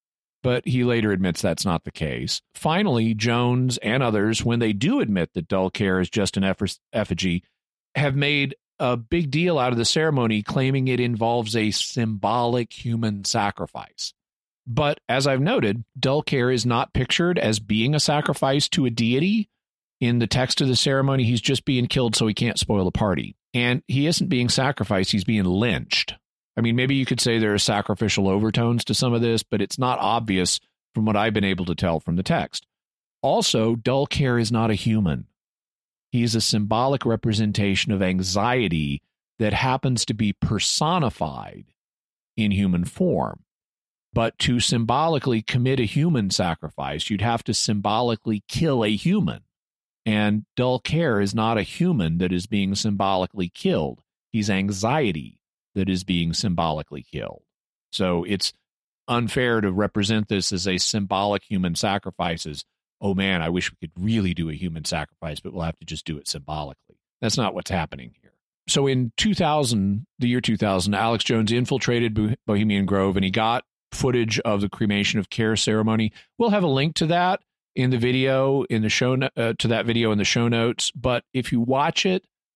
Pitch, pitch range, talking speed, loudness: 115 Hz, 100-125 Hz, 180 wpm, -22 LUFS